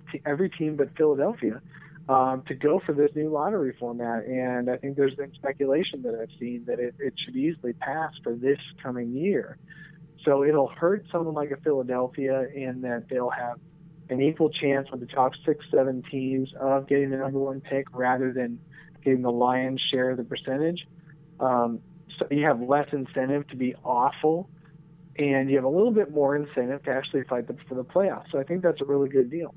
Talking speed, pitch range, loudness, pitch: 200 wpm, 130-155 Hz, -26 LUFS, 140 Hz